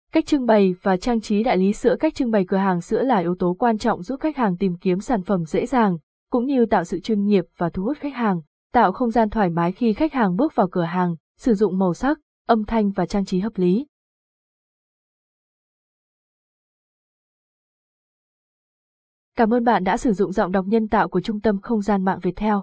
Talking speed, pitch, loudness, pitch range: 210 wpm, 215 Hz, -21 LUFS, 185-235 Hz